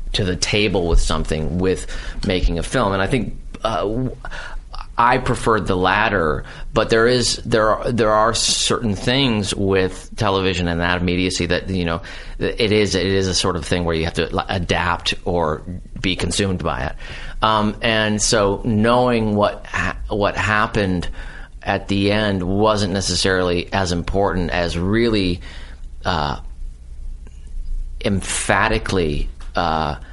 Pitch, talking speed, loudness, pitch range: 95 Hz, 145 wpm, -19 LUFS, 85-105 Hz